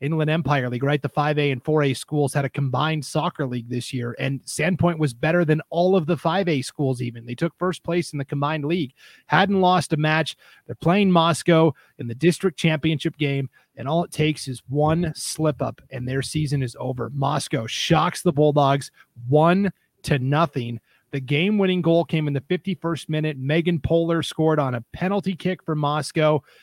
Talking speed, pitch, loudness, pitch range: 190 wpm, 155 Hz, -22 LUFS, 140-170 Hz